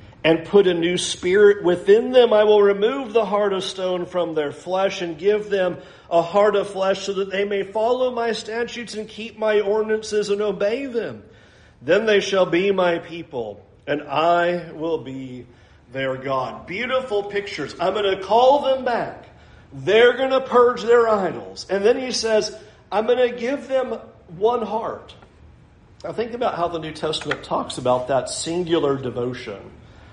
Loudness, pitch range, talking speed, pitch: -20 LUFS, 165-225 Hz, 175 wpm, 200 Hz